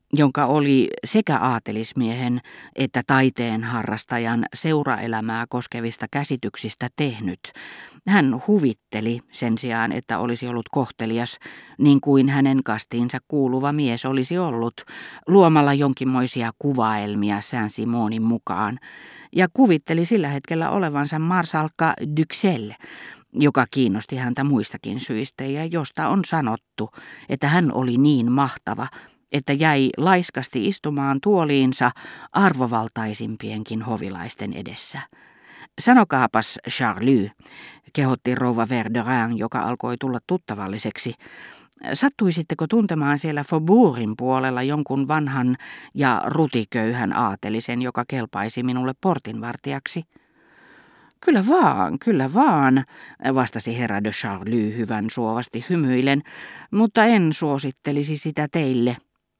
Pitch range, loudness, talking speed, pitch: 115-150 Hz, -22 LUFS, 100 wpm, 130 Hz